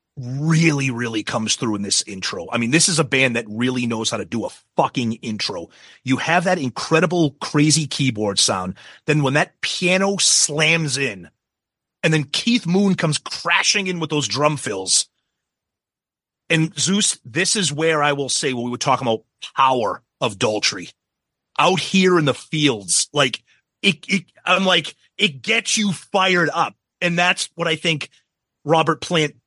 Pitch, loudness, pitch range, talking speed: 155 Hz, -19 LUFS, 130-180 Hz, 170 wpm